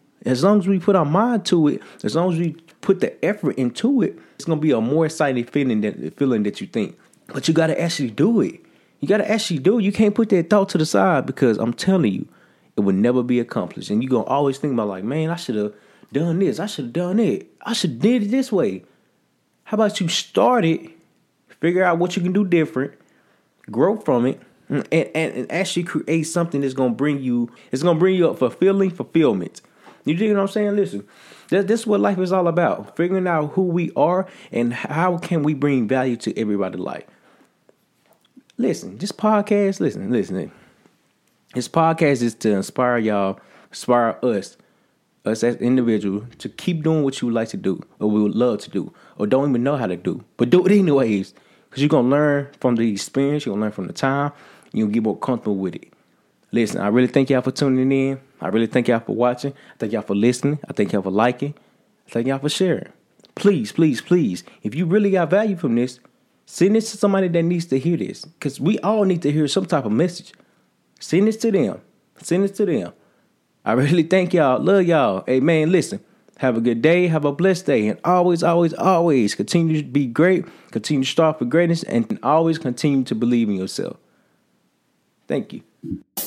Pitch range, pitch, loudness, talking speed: 125-185 Hz, 155 Hz, -20 LUFS, 215 wpm